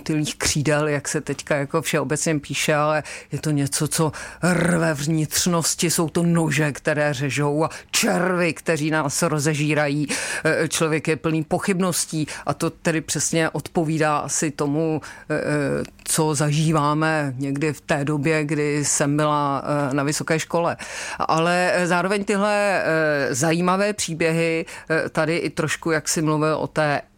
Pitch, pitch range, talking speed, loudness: 155 Hz, 150-165 Hz, 130 wpm, -21 LUFS